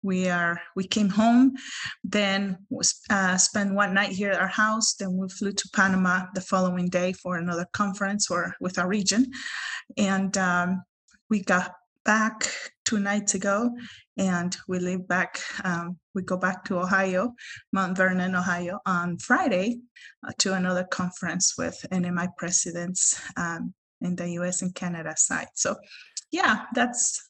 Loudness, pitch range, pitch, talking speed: -25 LUFS, 180-210 Hz, 190 Hz, 155 wpm